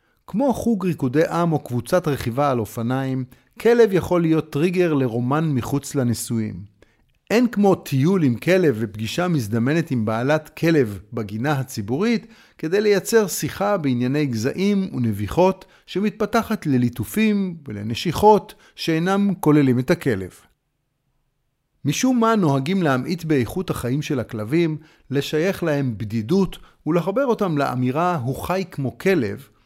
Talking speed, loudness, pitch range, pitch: 120 wpm, -21 LUFS, 125-185 Hz, 150 Hz